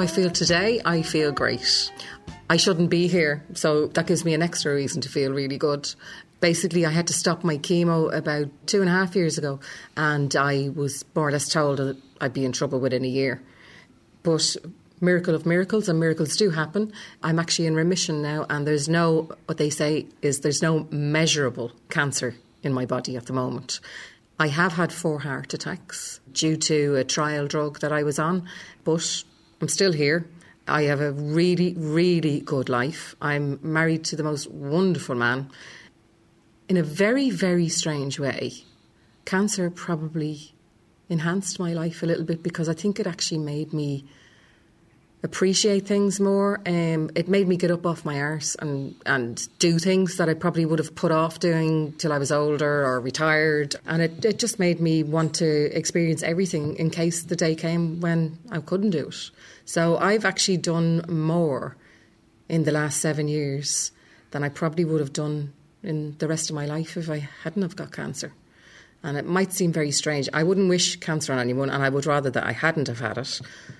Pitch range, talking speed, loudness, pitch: 145-170 Hz, 190 wpm, -24 LUFS, 160 Hz